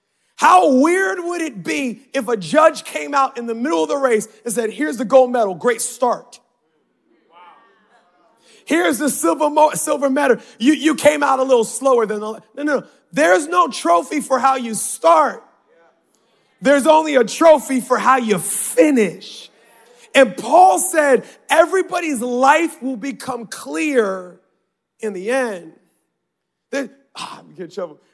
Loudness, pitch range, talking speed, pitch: -16 LUFS, 235-305 Hz, 160 wpm, 265 Hz